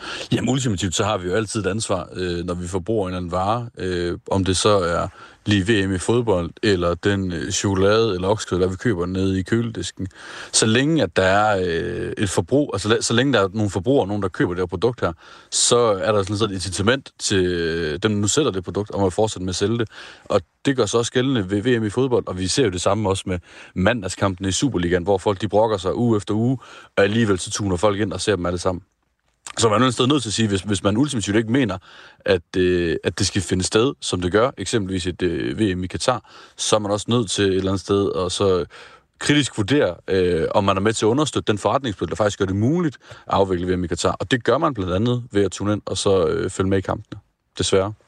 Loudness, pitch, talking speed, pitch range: -21 LUFS, 100 Hz, 255 wpm, 95-110 Hz